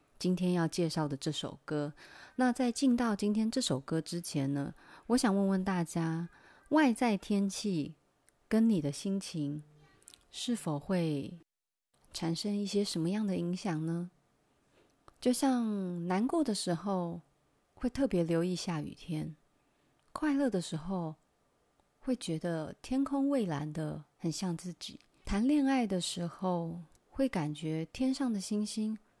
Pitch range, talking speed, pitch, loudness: 160-220 Hz, 195 characters per minute, 180 Hz, -33 LUFS